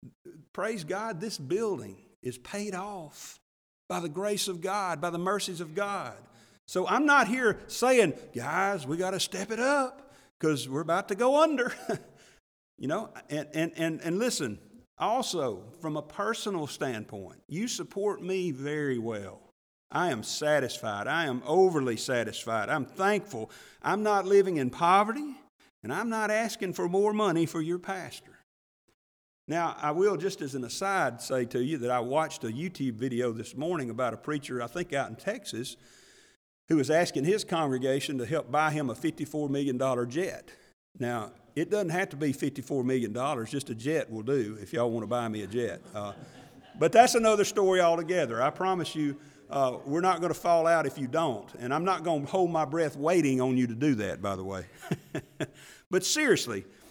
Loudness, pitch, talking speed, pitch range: -29 LUFS, 160 Hz, 185 wpm, 130-195 Hz